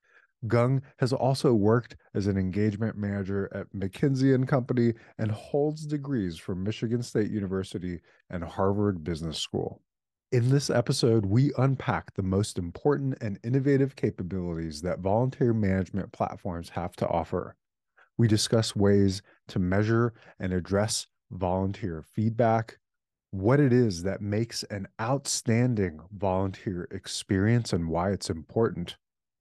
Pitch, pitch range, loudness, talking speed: 110 Hz, 95-120 Hz, -28 LUFS, 130 wpm